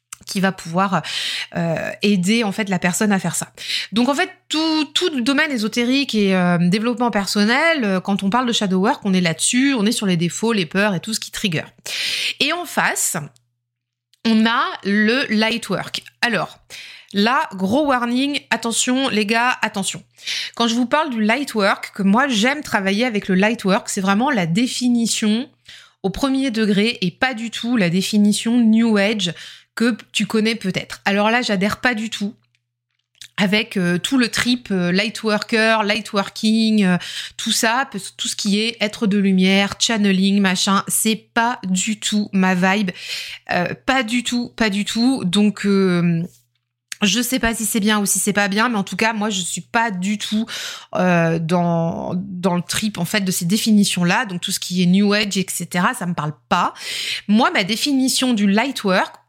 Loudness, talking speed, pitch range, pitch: -18 LUFS, 190 wpm, 190-235 Hz, 210 Hz